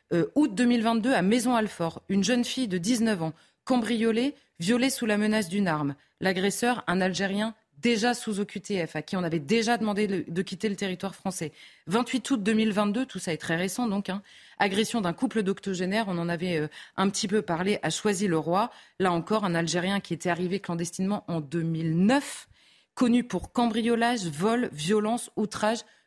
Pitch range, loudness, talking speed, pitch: 175-230 Hz, -27 LUFS, 175 wpm, 205 Hz